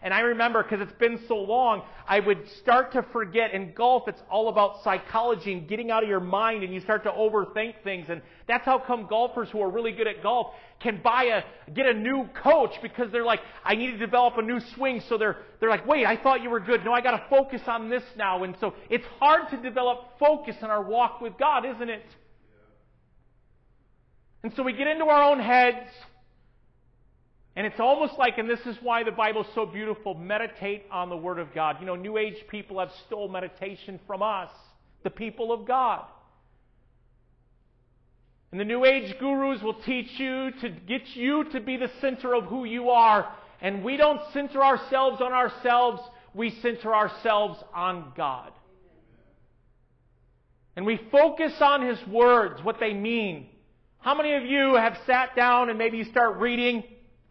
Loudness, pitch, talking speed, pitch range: -25 LUFS, 230 Hz, 195 wpm, 210-250 Hz